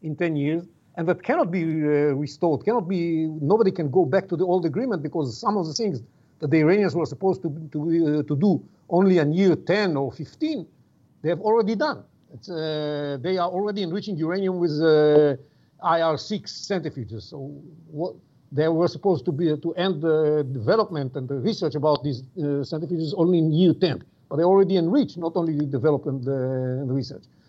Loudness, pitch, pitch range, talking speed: -23 LUFS, 160 Hz, 145-185 Hz, 195 wpm